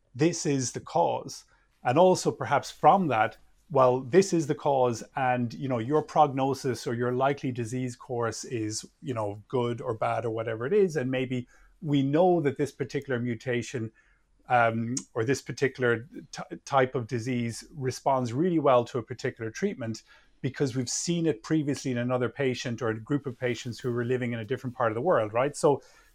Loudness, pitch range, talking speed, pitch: -28 LUFS, 120-145 Hz, 190 wpm, 130 Hz